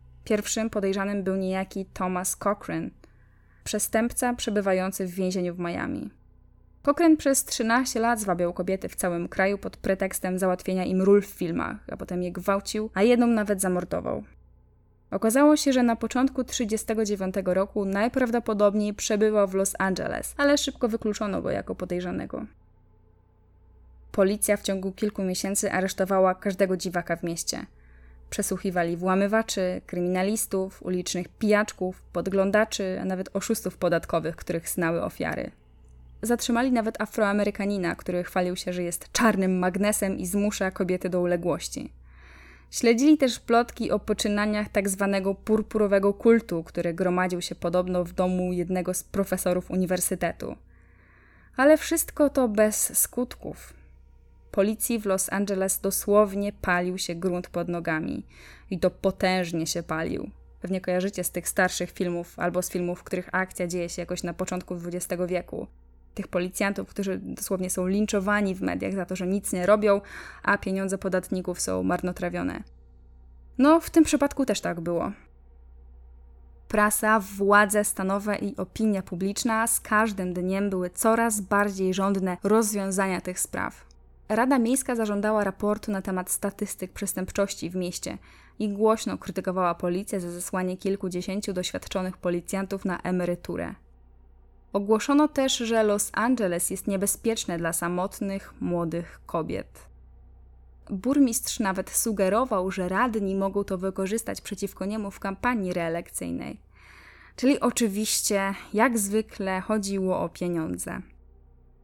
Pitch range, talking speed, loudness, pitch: 180-210 Hz, 130 wpm, -26 LUFS, 190 Hz